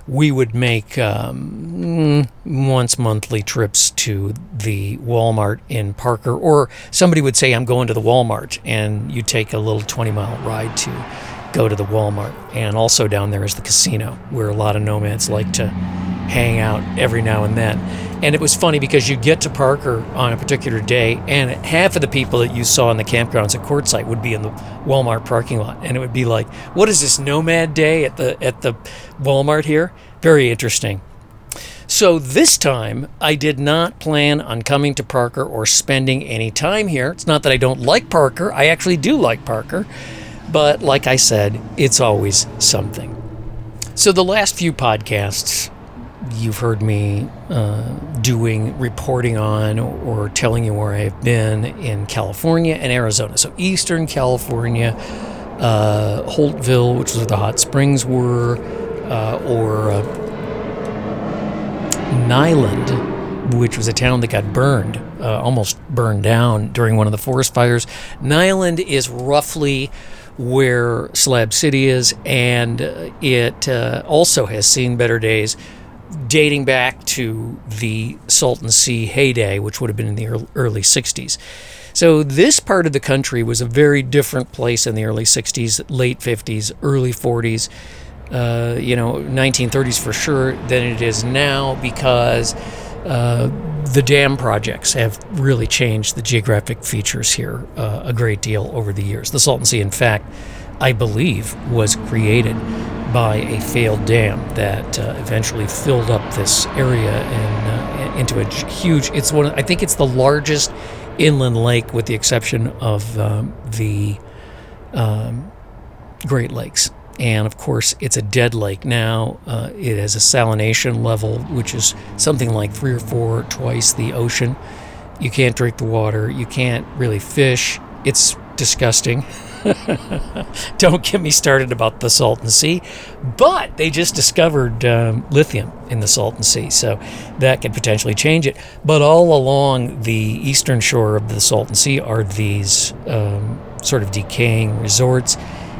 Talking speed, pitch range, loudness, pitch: 160 wpm, 110-135 Hz, -16 LUFS, 120 Hz